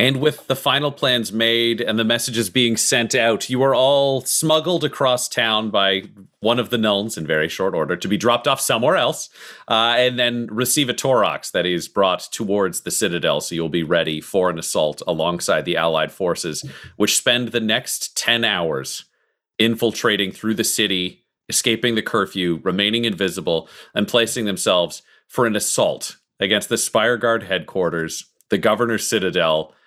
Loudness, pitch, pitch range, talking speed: -19 LUFS, 115 Hz, 100-125 Hz, 170 wpm